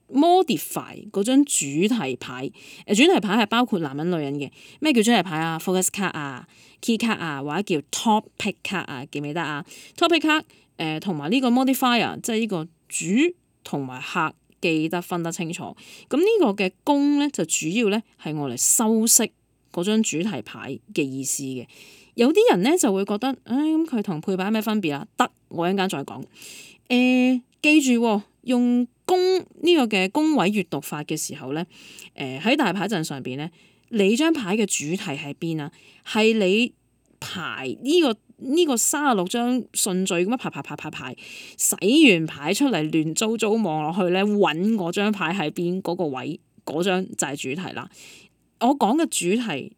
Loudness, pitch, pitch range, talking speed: -22 LUFS, 200 Hz, 160-245 Hz, 290 characters per minute